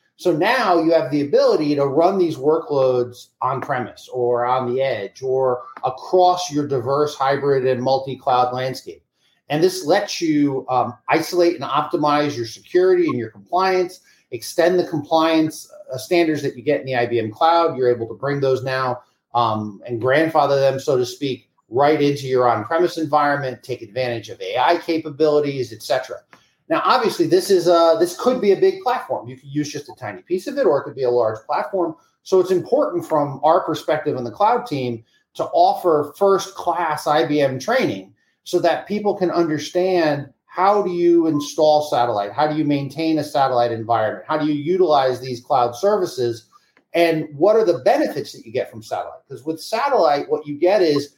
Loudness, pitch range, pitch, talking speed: -19 LUFS, 130-175 Hz, 150 Hz, 180 wpm